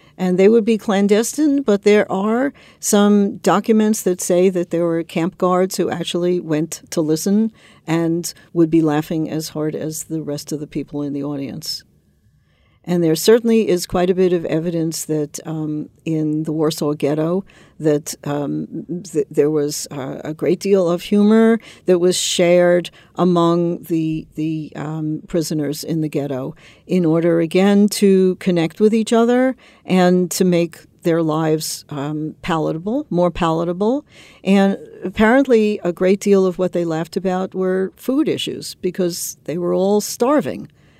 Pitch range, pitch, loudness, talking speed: 155-195 Hz, 175 Hz, -18 LUFS, 160 wpm